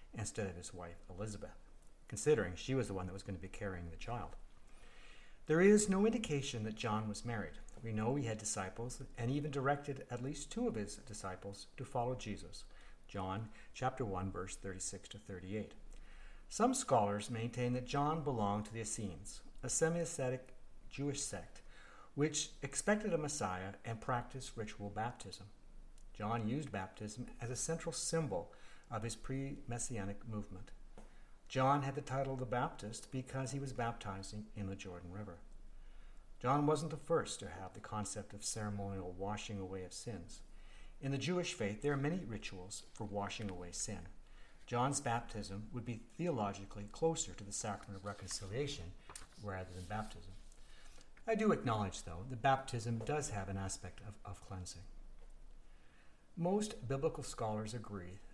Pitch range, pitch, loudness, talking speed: 100-135 Hz, 110 Hz, -40 LUFS, 160 wpm